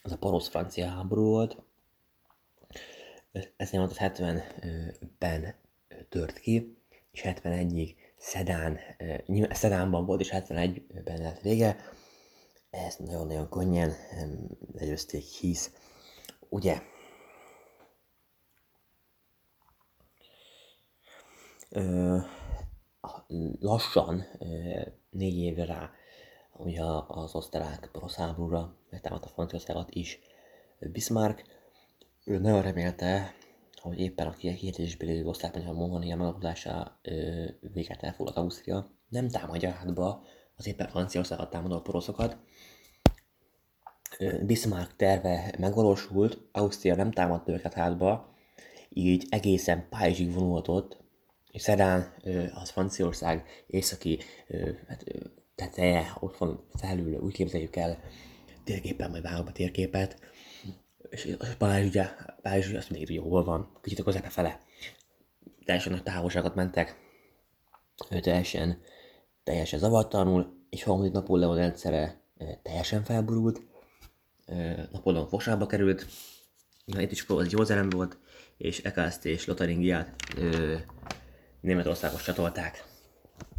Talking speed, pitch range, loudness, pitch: 95 wpm, 85-95 Hz, -31 LUFS, 90 Hz